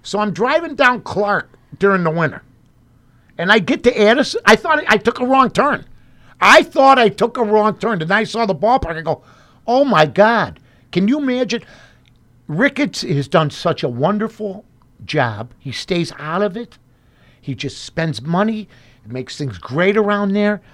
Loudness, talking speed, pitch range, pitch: -16 LUFS, 180 wpm, 135-225 Hz, 195 Hz